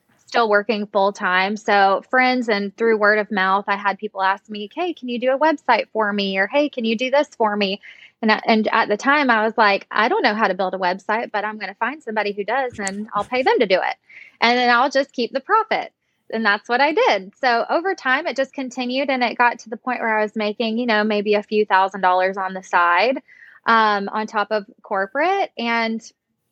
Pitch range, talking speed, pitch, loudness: 205-245 Hz, 245 wpm, 220 Hz, -19 LUFS